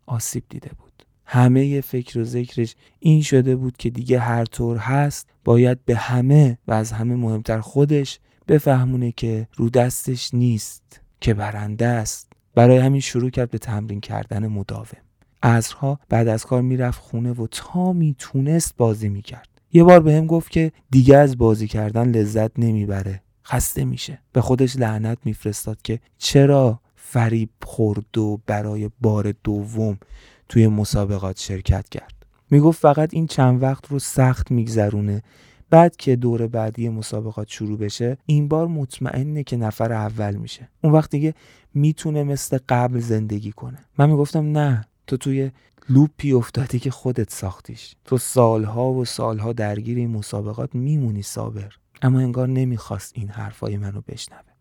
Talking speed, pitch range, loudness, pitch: 150 wpm, 110-135 Hz, -20 LUFS, 120 Hz